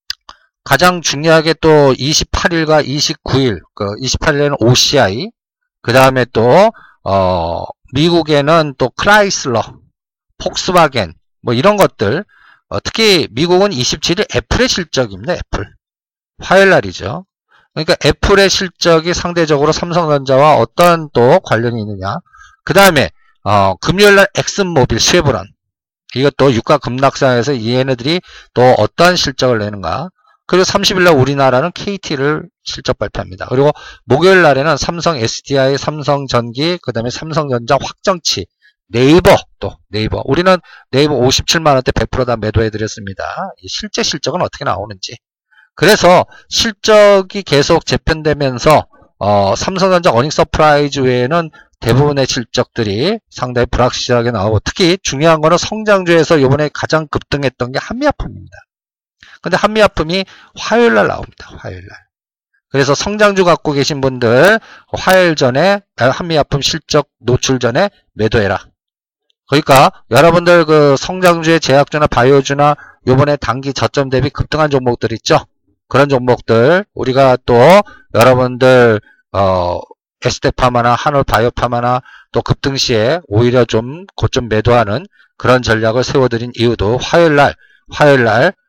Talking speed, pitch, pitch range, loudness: 305 characters per minute, 140 Hz, 120-175 Hz, -12 LUFS